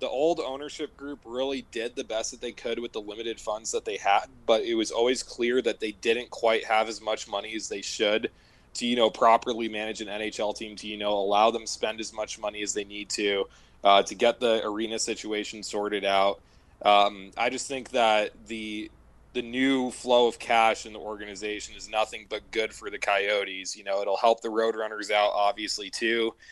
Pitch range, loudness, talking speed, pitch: 105-120 Hz, -27 LUFS, 210 wpm, 110 Hz